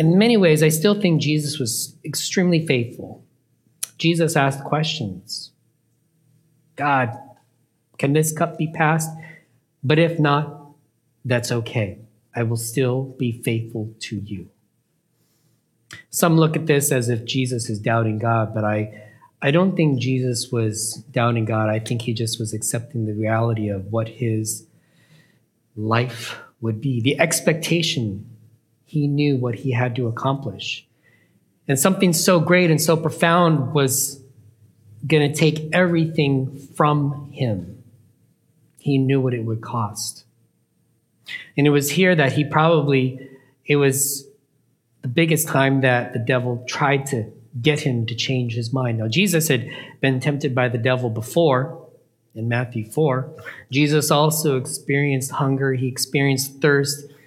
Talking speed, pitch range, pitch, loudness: 140 wpm, 115-150 Hz, 135 Hz, -20 LUFS